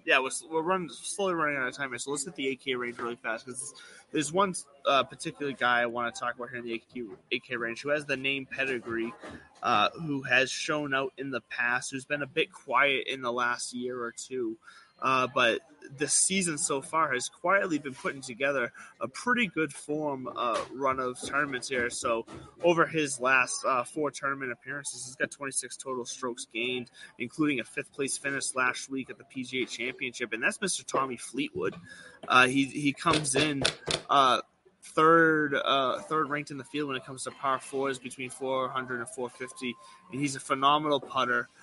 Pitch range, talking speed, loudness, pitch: 125-150 Hz, 200 wpm, -29 LUFS, 135 Hz